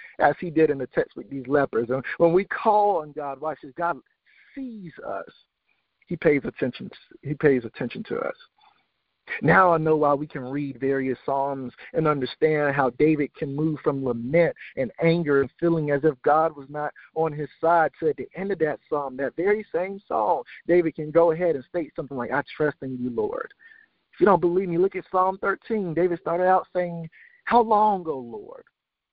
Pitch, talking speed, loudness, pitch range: 160 Hz, 205 wpm, -24 LUFS, 145-185 Hz